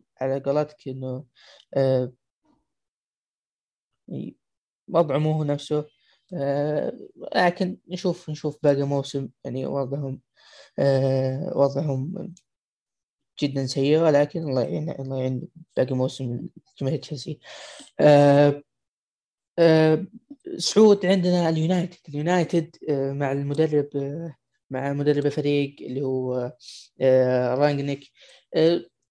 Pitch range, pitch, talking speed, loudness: 135-165 Hz, 145 Hz, 95 wpm, -23 LUFS